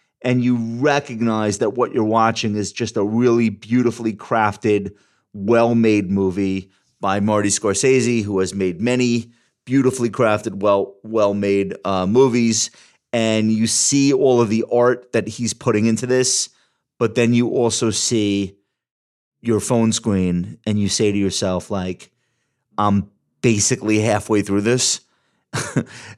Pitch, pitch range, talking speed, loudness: 110 Hz, 100-120 Hz, 140 wpm, -18 LUFS